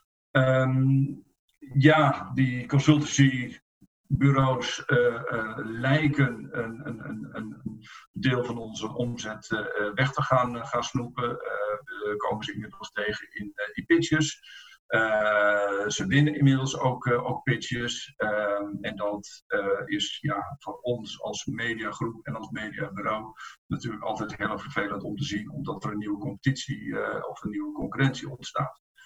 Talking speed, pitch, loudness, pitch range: 140 wpm, 130 Hz, -27 LUFS, 110-140 Hz